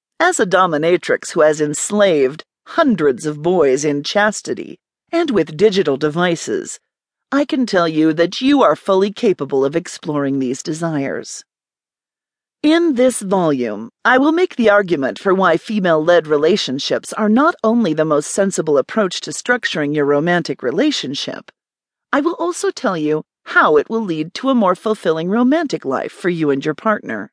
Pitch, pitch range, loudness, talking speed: 190 Hz, 155-245 Hz, -16 LUFS, 160 wpm